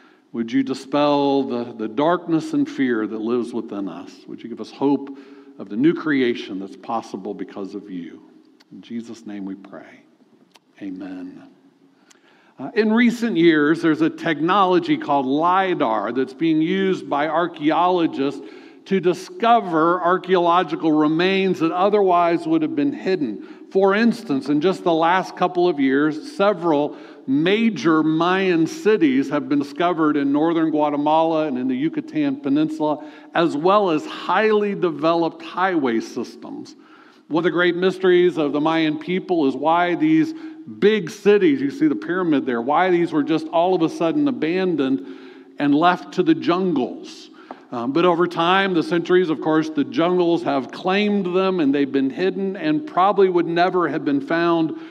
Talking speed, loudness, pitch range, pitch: 155 wpm, -19 LUFS, 155-235 Hz, 175 Hz